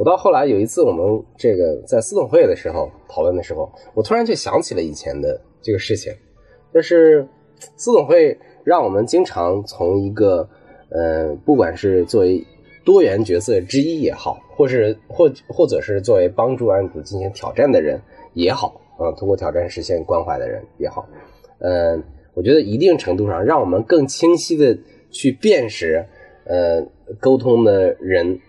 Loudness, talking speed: -17 LUFS, 260 characters per minute